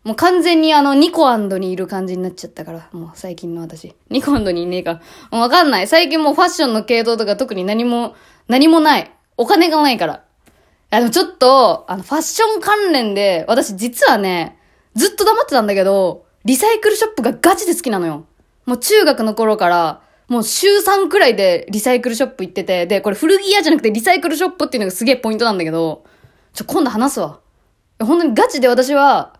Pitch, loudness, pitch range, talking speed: 250 Hz, -14 LUFS, 195-325 Hz, 430 characters per minute